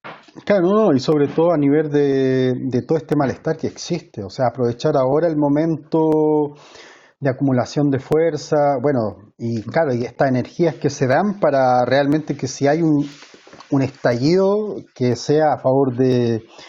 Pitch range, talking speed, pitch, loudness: 130-155 Hz, 165 wpm, 145 Hz, -18 LUFS